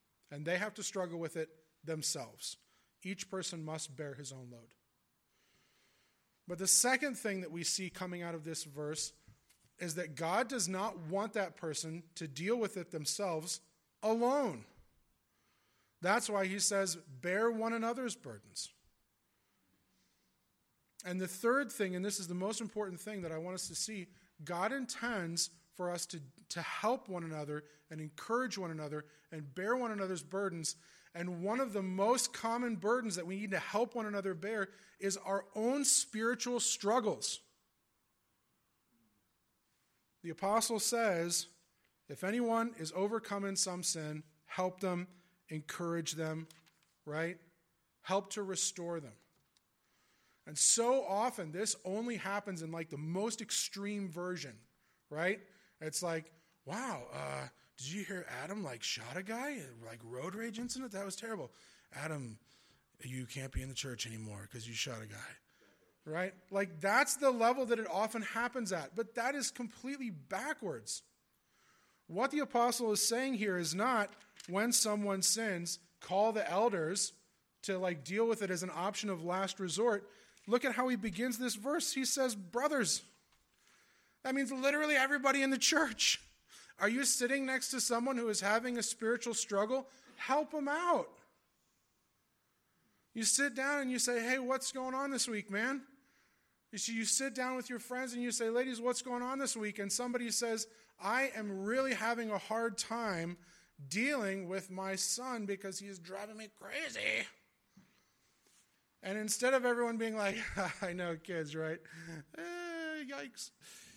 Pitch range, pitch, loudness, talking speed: 170-235 Hz, 200 Hz, -36 LUFS, 160 wpm